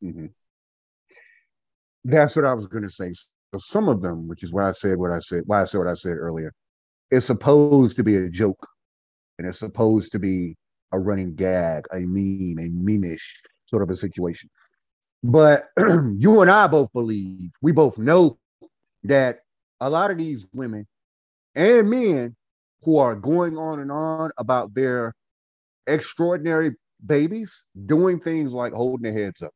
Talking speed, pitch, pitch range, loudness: 165 wpm, 110 Hz, 90-145 Hz, -21 LUFS